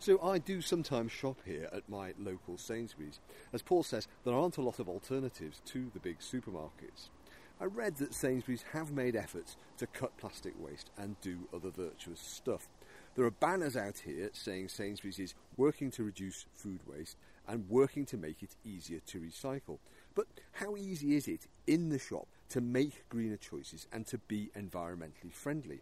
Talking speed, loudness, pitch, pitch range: 180 wpm, -39 LUFS, 115 Hz, 95-140 Hz